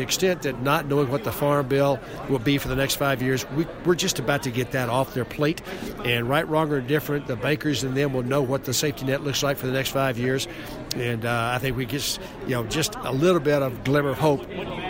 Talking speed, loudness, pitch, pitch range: 255 wpm, -24 LUFS, 140 Hz, 130-150 Hz